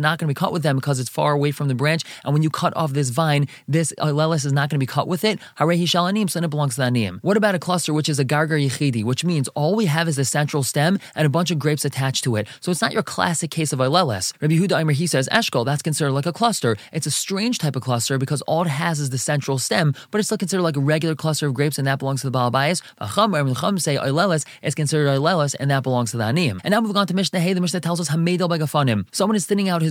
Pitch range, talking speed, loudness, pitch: 140-175 Hz, 275 wpm, -21 LUFS, 155 Hz